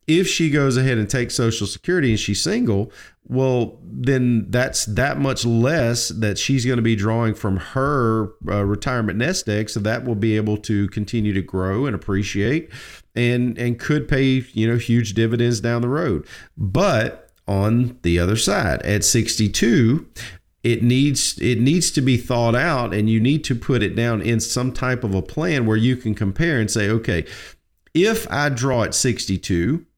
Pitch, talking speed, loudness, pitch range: 115 Hz, 180 wpm, -20 LUFS, 105-130 Hz